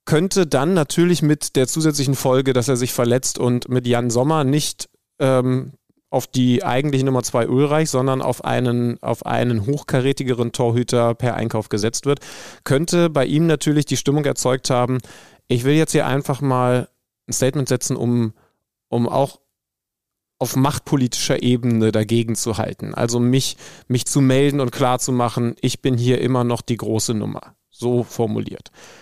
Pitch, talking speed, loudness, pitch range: 125 Hz, 165 wpm, -19 LUFS, 120-140 Hz